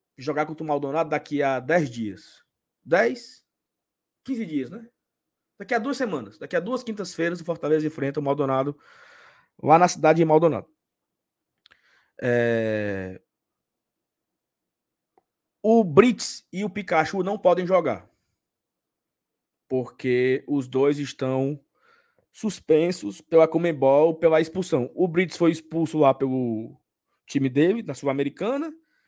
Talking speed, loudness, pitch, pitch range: 120 wpm, -23 LUFS, 160 Hz, 135-200 Hz